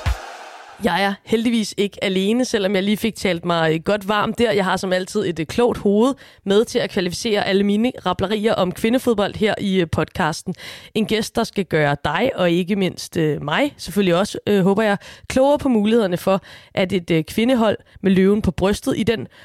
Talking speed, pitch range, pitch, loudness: 190 wpm, 185-220 Hz, 200 Hz, -19 LUFS